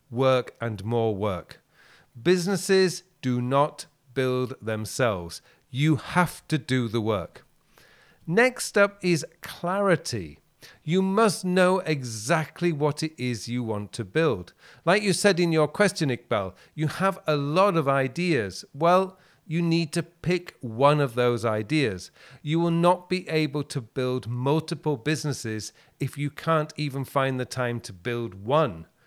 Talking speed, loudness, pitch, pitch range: 145 wpm, -25 LUFS, 150 Hz, 125-175 Hz